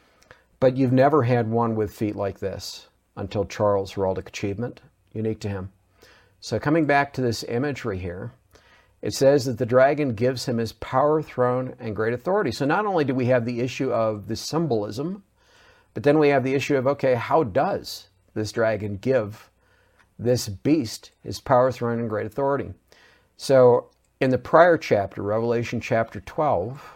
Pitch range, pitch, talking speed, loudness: 105-135 Hz, 120 Hz, 170 wpm, -23 LUFS